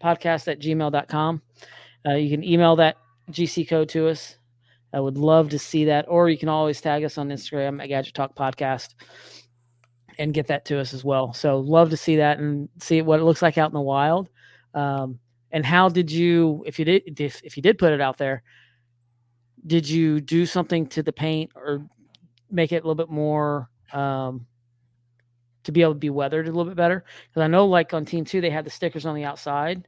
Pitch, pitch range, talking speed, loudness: 150 Hz, 135-165 Hz, 215 wpm, -22 LUFS